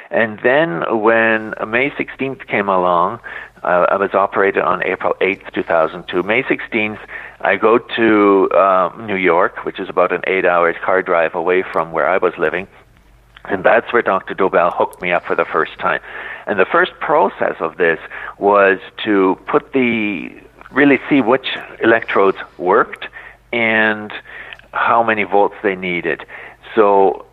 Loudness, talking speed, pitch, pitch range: -16 LUFS, 155 wpm, 100 Hz, 95-110 Hz